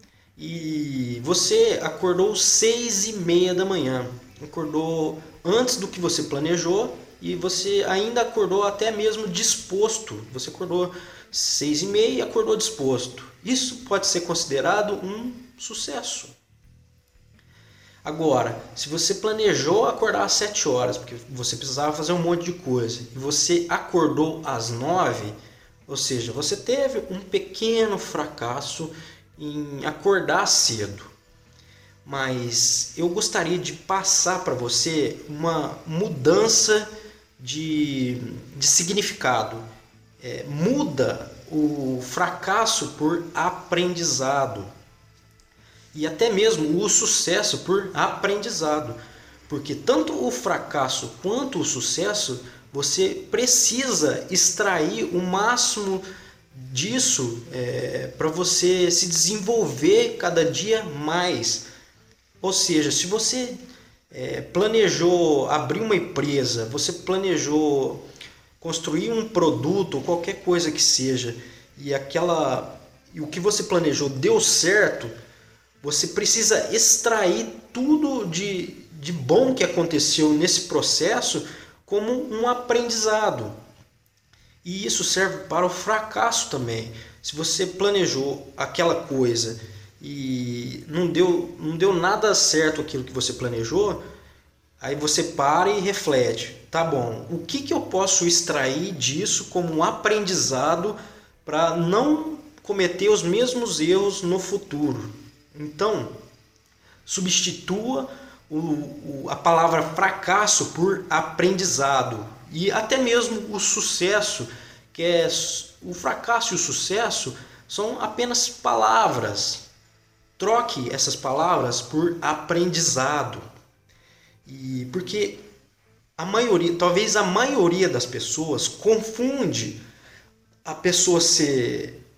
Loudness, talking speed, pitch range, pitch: -22 LUFS, 110 wpm, 135-200 Hz, 165 Hz